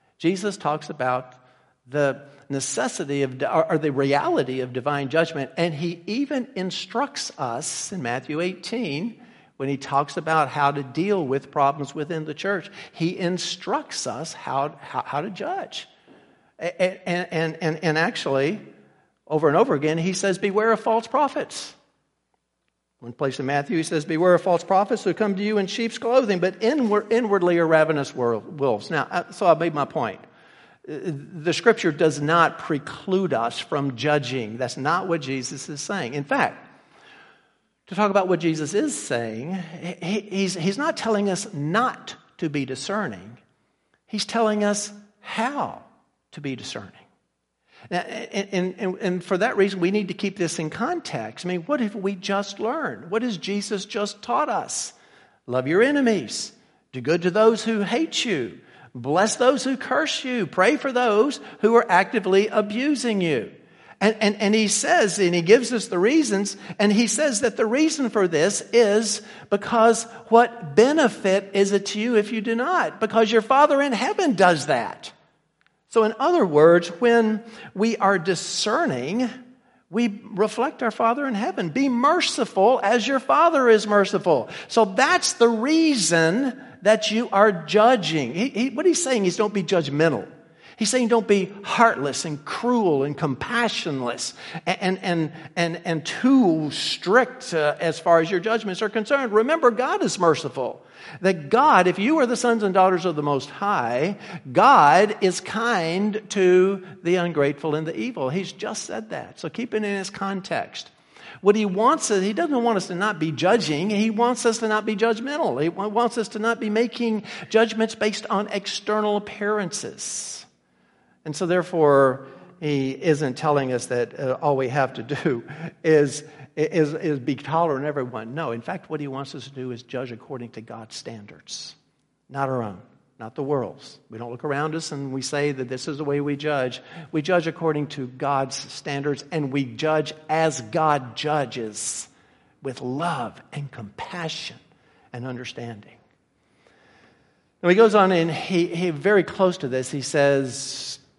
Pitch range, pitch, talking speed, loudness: 145-220 Hz, 180 Hz, 170 wpm, -22 LUFS